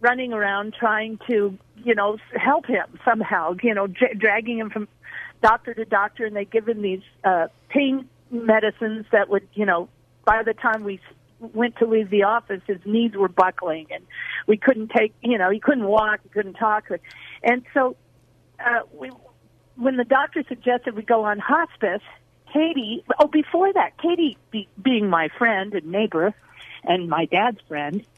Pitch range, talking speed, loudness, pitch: 200-245 Hz, 175 wpm, -22 LUFS, 220 Hz